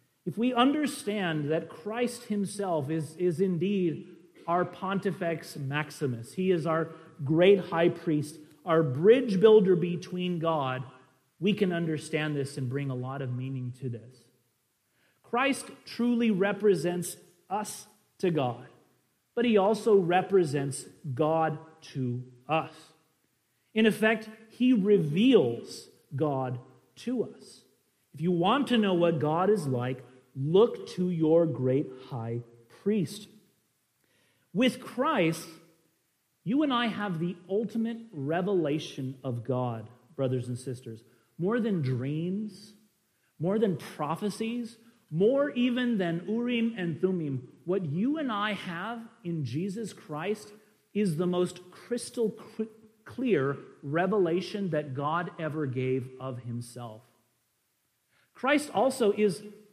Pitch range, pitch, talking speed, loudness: 140-210 Hz, 170 Hz, 120 wpm, -29 LUFS